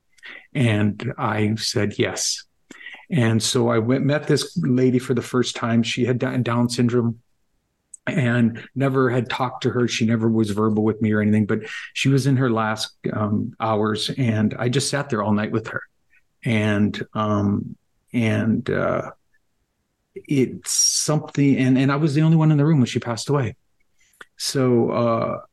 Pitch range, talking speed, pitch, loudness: 110-130 Hz, 170 wpm, 120 Hz, -21 LUFS